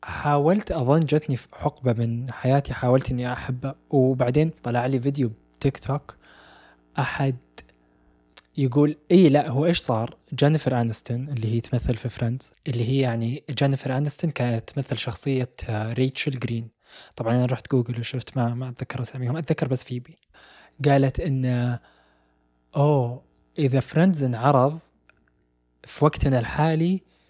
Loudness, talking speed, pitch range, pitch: -24 LUFS, 135 wpm, 120-145 Hz, 130 Hz